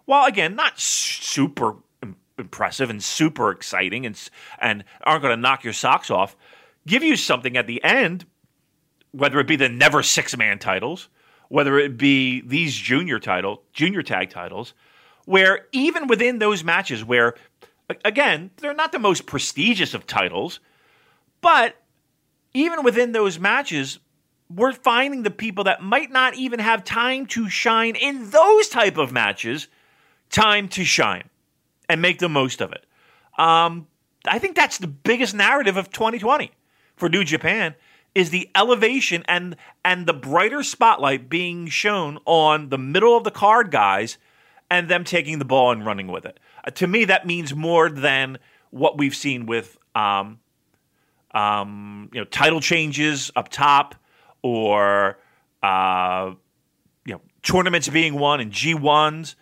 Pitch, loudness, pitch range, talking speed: 165 Hz, -19 LUFS, 140-220 Hz, 155 wpm